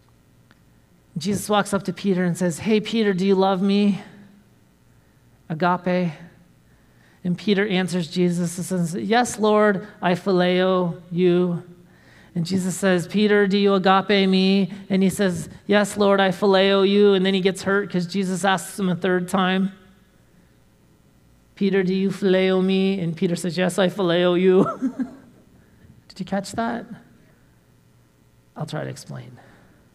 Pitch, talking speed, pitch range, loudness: 190 Hz, 145 wpm, 180-200 Hz, -21 LUFS